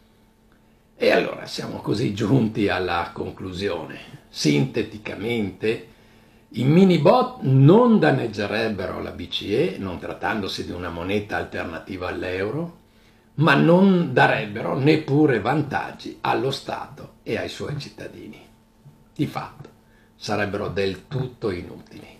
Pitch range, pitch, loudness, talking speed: 105-150 Hz, 110 Hz, -22 LUFS, 105 wpm